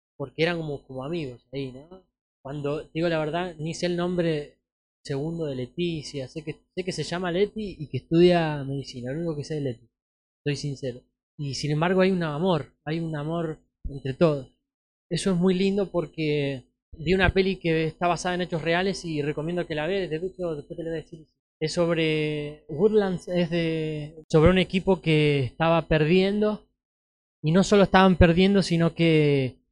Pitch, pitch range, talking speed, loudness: 160 Hz, 145-175 Hz, 185 wpm, -25 LUFS